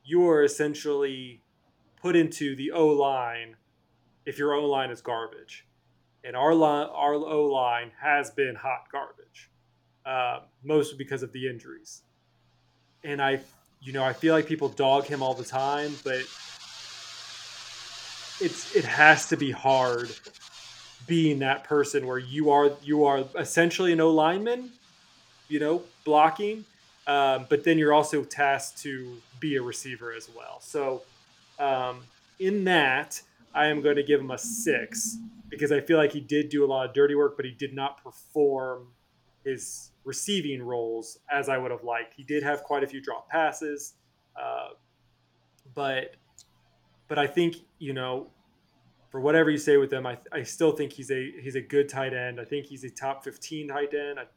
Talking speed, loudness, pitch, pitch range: 170 wpm, -26 LUFS, 145 Hz, 130-150 Hz